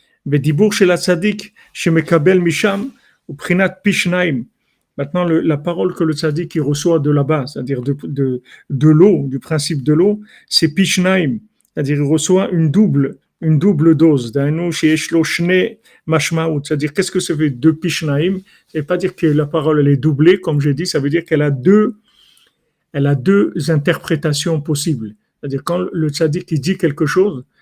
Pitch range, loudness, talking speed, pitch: 150-185 Hz, -15 LUFS, 145 wpm, 160 Hz